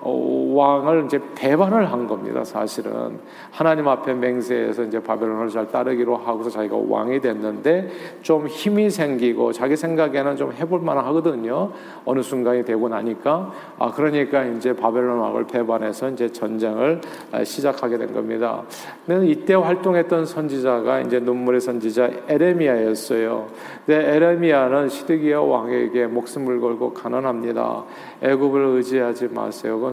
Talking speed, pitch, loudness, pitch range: 330 characters per minute, 130 Hz, -21 LUFS, 120-155 Hz